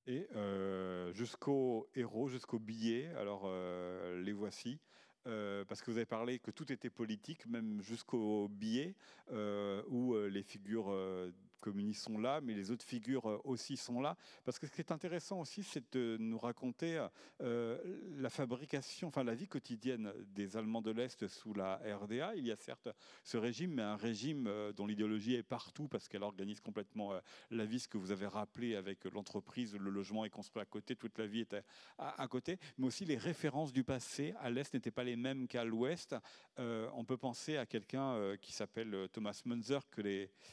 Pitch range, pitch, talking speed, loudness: 105-130 Hz, 115 Hz, 195 wpm, -43 LUFS